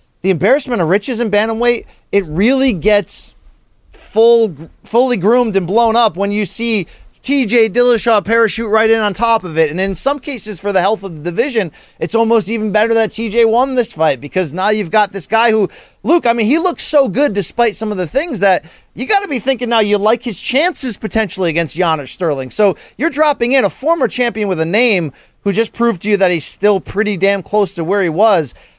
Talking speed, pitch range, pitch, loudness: 215 wpm, 195-235 Hz, 220 Hz, -14 LUFS